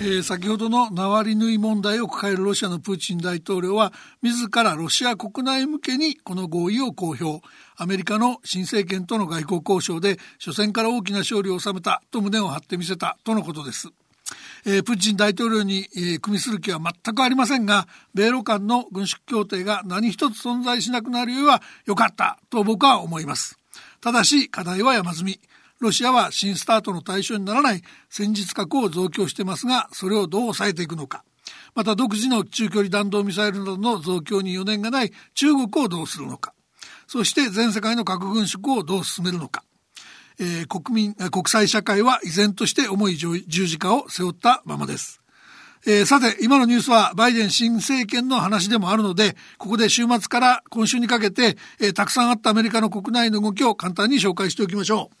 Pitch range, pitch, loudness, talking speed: 195-235 Hz, 210 Hz, -21 LUFS, 380 characters per minute